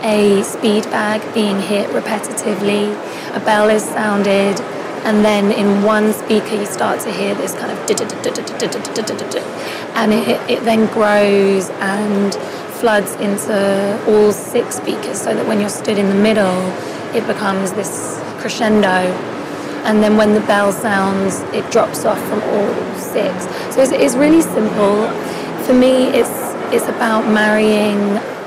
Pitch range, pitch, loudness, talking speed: 200-220 Hz, 210 Hz, -15 LUFS, 145 wpm